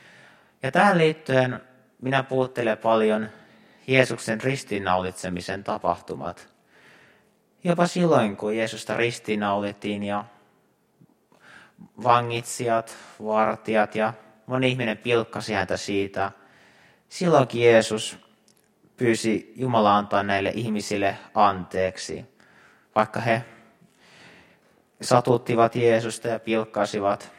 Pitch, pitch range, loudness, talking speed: 110 Hz, 105-120 Hz, -24 LUFS, 80 wpm